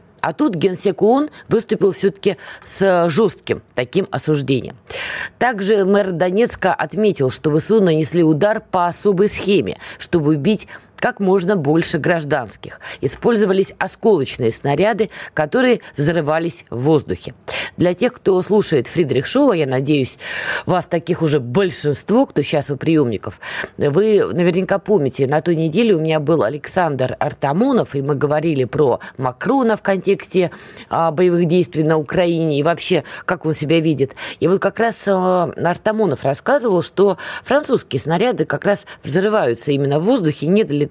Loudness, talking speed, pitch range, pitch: -17 LUFS, 145 wpm, 150-200 Hz, 175 Hz